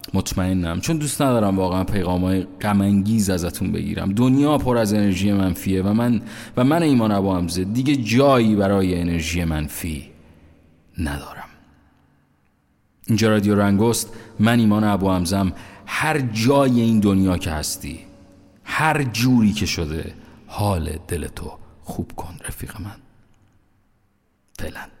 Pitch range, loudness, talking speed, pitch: 90-115 Hz, -20 LUFS, 125 wpm, 100 Hz